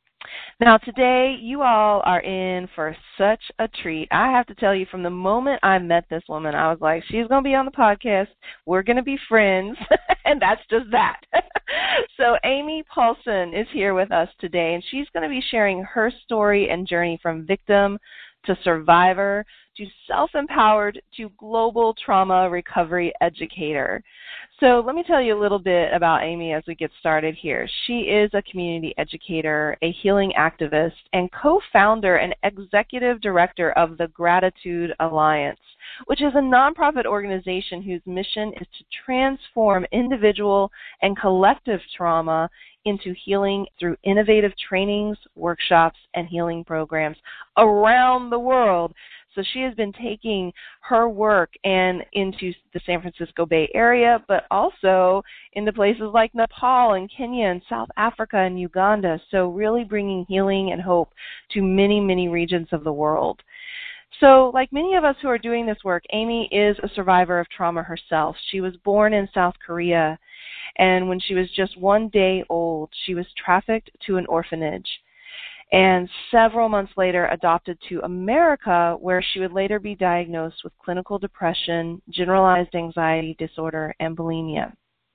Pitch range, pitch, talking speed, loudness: 175-225 Hz, 195 Hz, 160 wpm, -20 LUFS